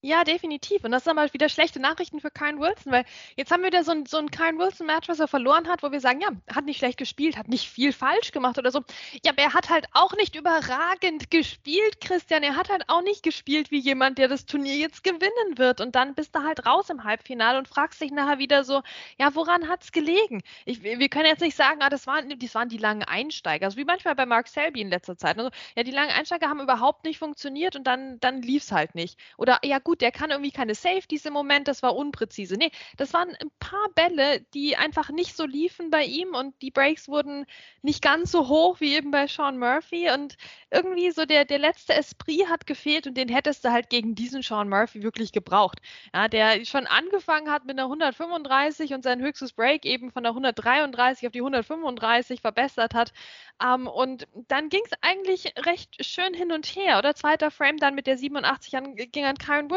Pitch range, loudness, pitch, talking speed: 255-320 Hz, -24 LUFS, 290 Hz, 225 wpm